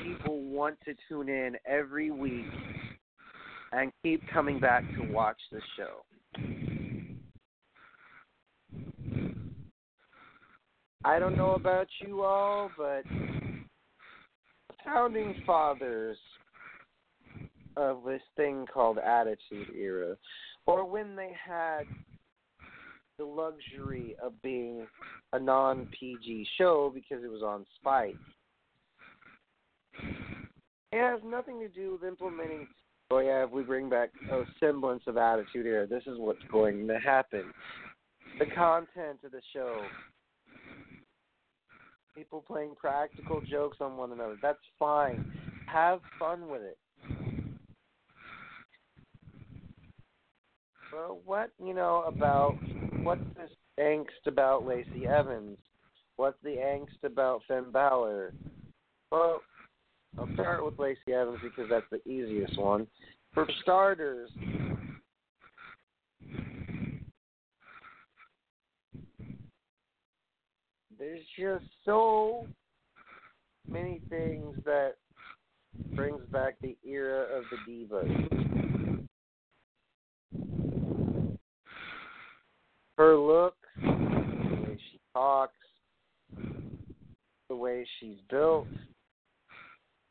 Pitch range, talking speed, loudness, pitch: 130-185 Hz, 95 wpm, -32 LUFS, 150 Hz